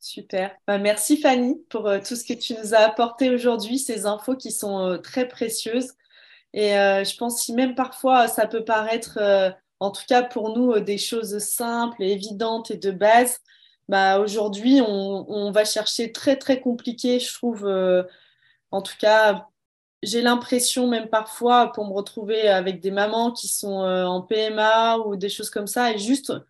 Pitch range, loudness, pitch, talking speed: 200-245 Hz, -22 LUFS, 220 Hz, 185 wpm